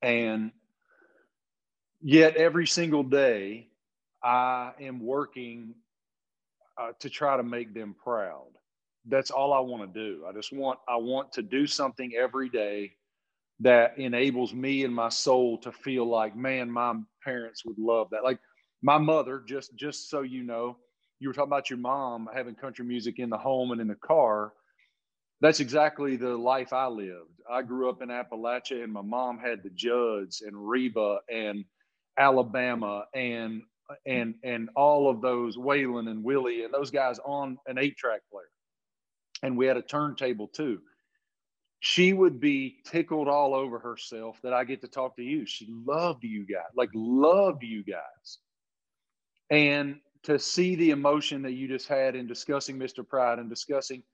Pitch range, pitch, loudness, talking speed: 115-140 Hz, 125 Hz, -28 LUFS, 165 wpm